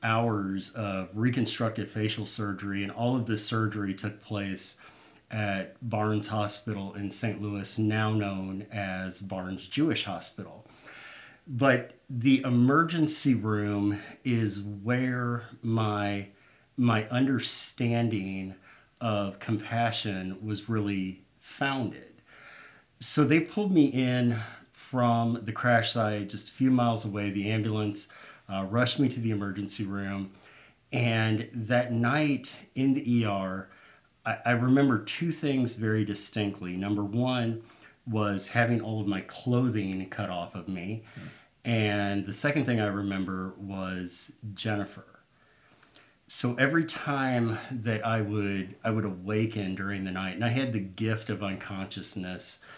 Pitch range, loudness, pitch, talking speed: 100-120 Hz, -29 LUFS, 110 Hz, 130 wpm